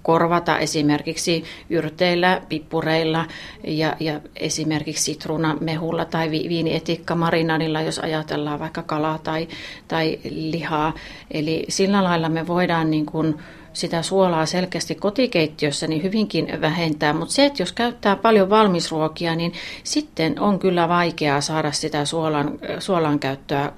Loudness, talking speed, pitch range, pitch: -21 LUFS, 120 wpm, 155-170 Hz, 160 Hz